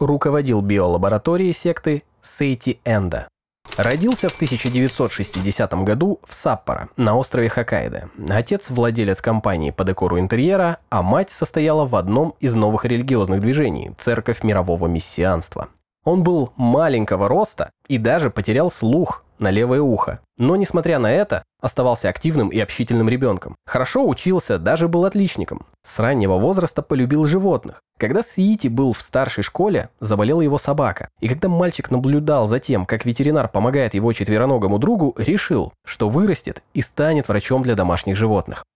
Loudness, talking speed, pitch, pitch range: -19 LUFS, 140 wpm, 125 Hz, 105-150 Hz